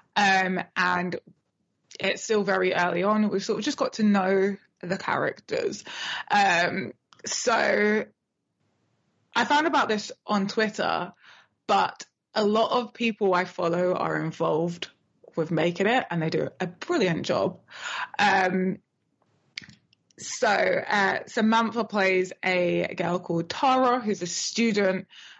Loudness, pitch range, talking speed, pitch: -25 LUFS, 180-225 Hz, 130 wpm, 195 Hz